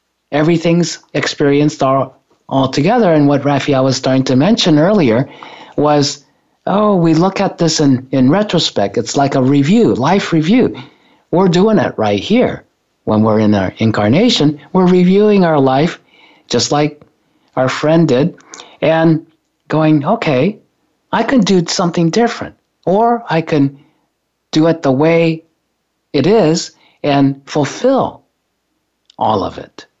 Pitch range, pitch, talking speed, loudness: 140-180 Hz, 155 Hz, 140 wpm, -13 LUFS